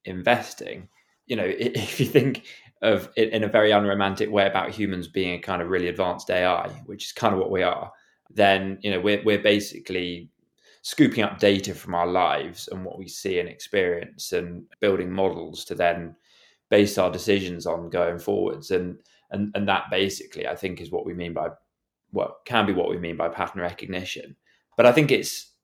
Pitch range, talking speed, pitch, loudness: 85-100 Hz, 195 wpm, 95 Hz, -24 LUFS